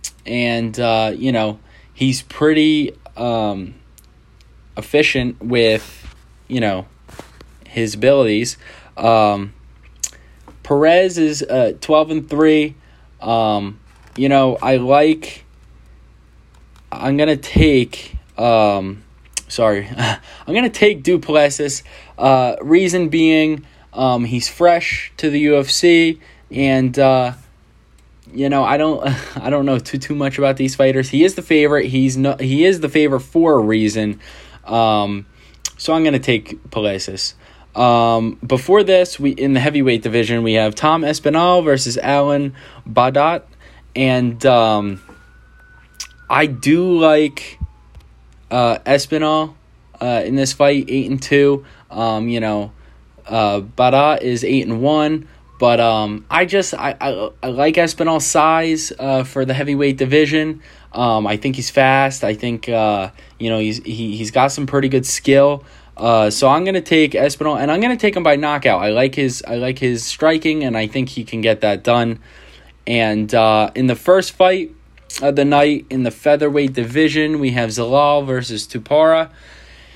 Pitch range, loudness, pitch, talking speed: 110-150 Hz, -16 LUFS, 130 Hz, 145 wpm